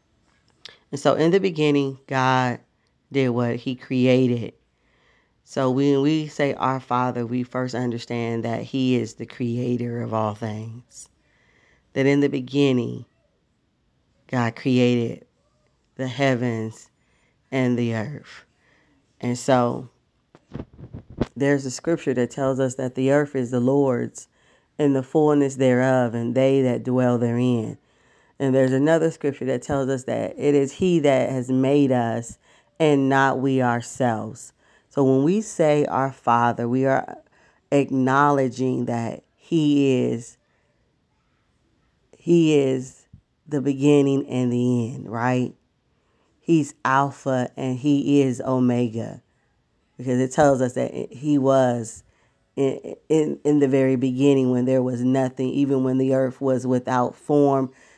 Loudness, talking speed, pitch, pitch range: -22 LUFS, 135 wpm, 130 Hz, 120-140 Hz